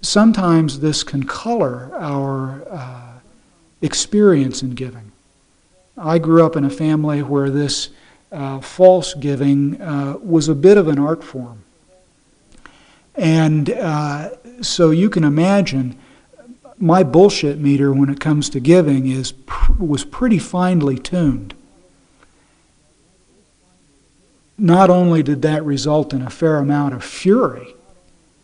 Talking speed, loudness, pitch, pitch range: 125 wpm, -16 LUFS, 150 Hz, 135-170 Hz